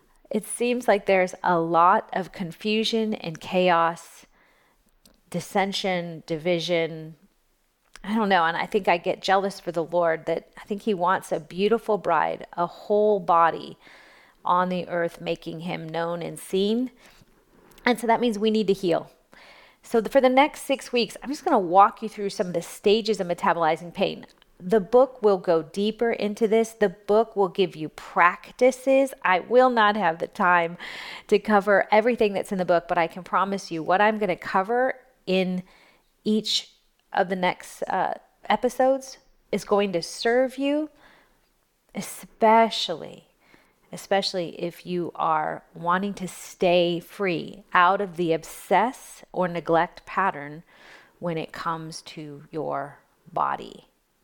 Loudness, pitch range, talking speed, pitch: -24 LUFS, 170-220 Hz, 155 wpm, 195 Hz